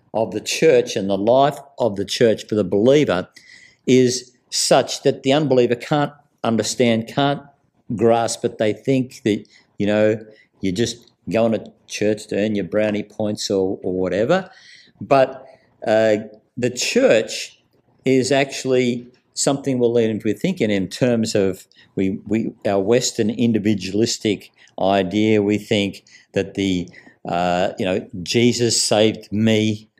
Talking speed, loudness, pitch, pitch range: 140 wpm, -19 LUFS, 110 Hz, 105-125 Hz